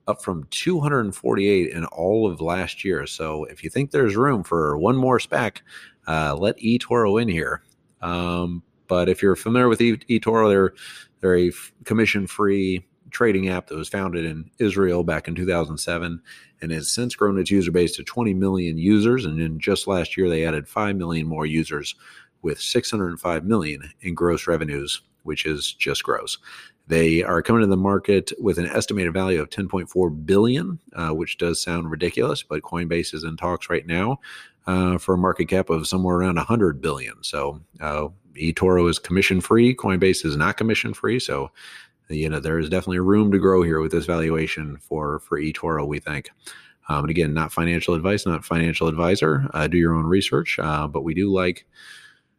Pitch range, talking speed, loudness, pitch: 80-100 Hz, 185 wpm, -22 LUFS, 90 Hz